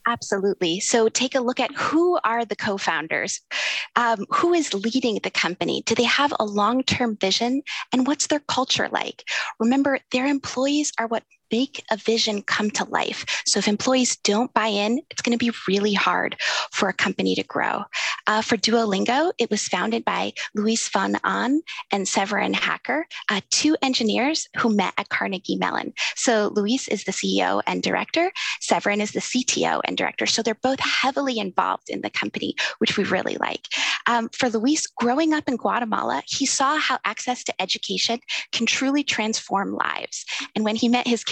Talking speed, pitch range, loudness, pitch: 180 wpm, 215-275 Hz, -22 LUFS, 235 Hz